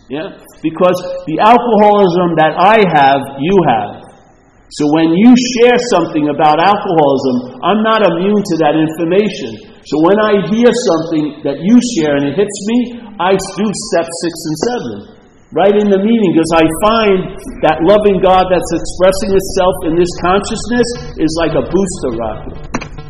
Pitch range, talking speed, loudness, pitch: 160-210 Hz, 160 wpm, -12 LUFS, 185 Hz